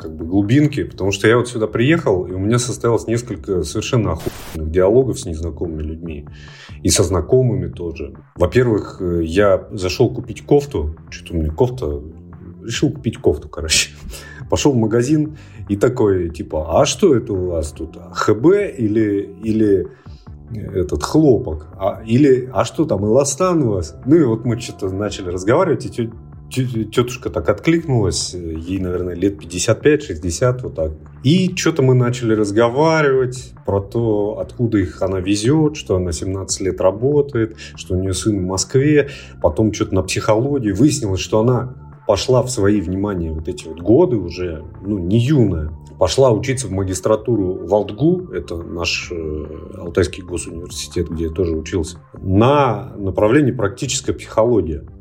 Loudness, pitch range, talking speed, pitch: -18 LUFS, 85-120 Hz, 150 wpm, 100 Hz